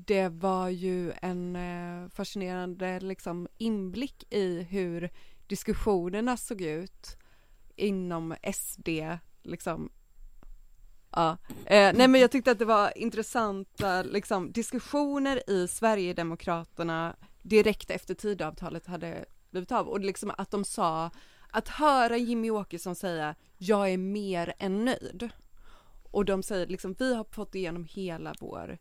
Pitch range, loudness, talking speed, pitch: 175-215 Hz, -30 LUFS, 130 wpm, 190 Hz